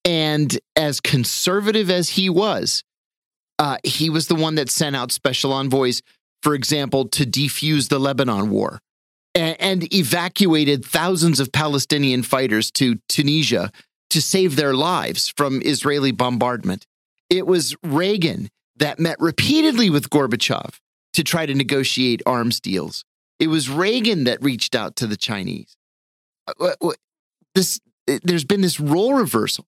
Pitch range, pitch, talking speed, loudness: 135-175 Hz, 150 Hz, 135 wpm, -19 LUFS